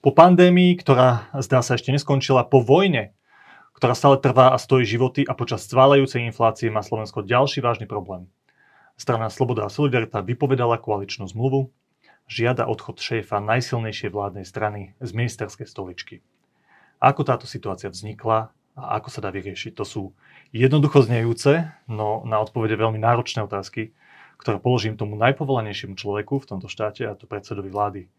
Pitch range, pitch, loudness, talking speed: 105-135 Hz, 115 Hz, -21 LUFS, 150 wpm